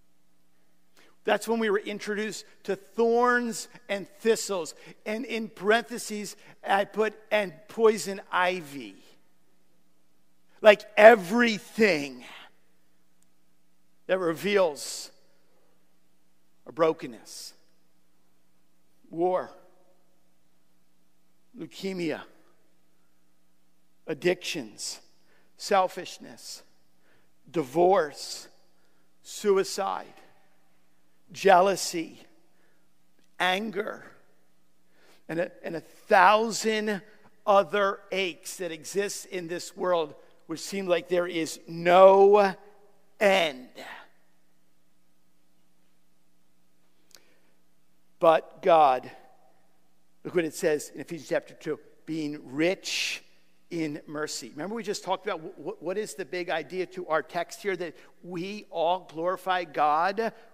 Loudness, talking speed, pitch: -26 LUFS, 80 wpm, 165 Hz